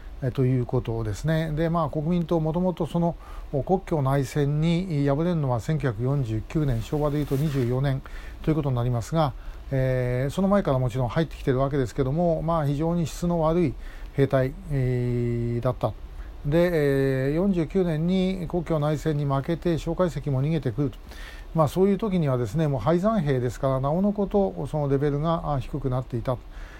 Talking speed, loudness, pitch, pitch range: 330 characters per minute, -25 LUFS, 145 Hz, 130-165 Hz